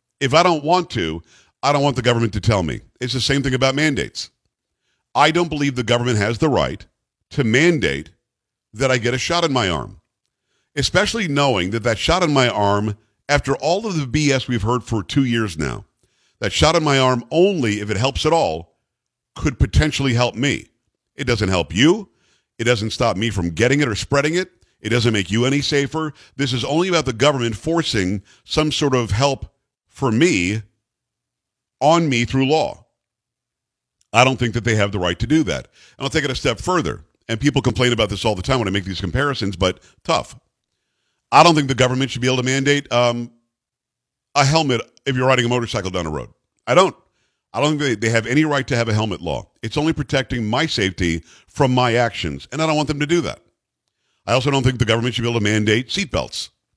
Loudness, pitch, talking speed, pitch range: -19 LUFS, 125 Hz, 215 wpm, 115-145 Hz